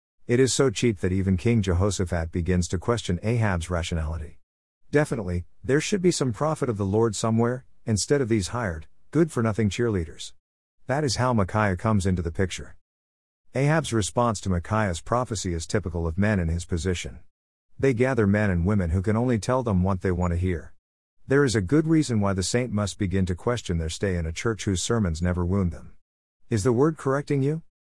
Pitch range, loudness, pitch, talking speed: 90-120 Hz, -25 LUFS, 100 Hz, 200 wpm